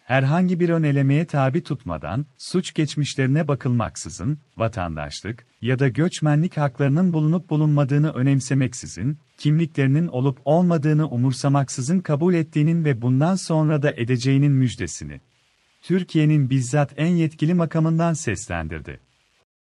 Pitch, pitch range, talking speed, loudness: 145 Hz, 130-160 Hz, 105 wpm, -21 LUFS